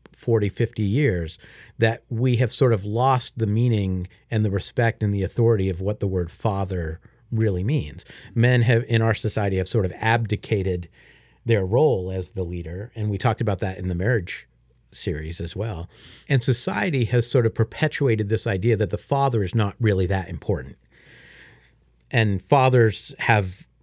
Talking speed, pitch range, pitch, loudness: 170 wpm, 95-115 Hz, 110 Hz, -23 LUFS